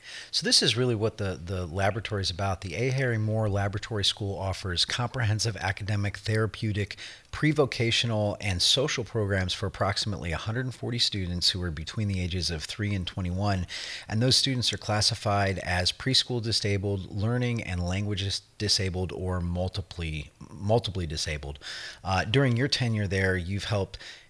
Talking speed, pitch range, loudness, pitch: 150 wpm, 95-115 Hz, -27 LUFS, 100 Hz